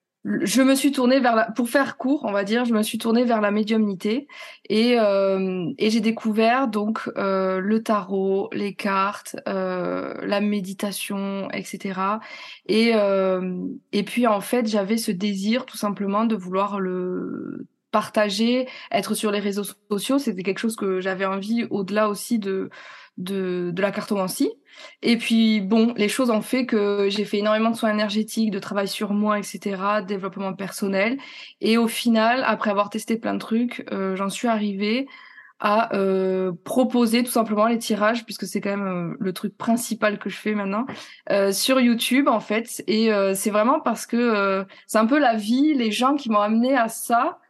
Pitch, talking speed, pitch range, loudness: 215 Hz, 185 wpm, 200-235 Hz, -22 LUFS